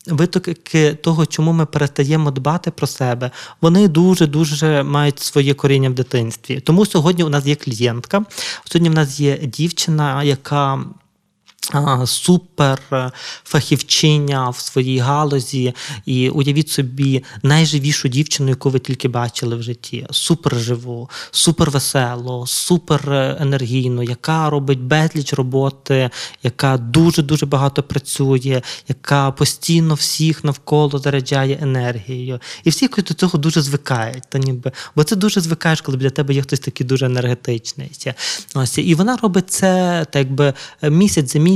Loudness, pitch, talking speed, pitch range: -17 LUFS, 145 Hz, 135 wpm, 130-160 Hz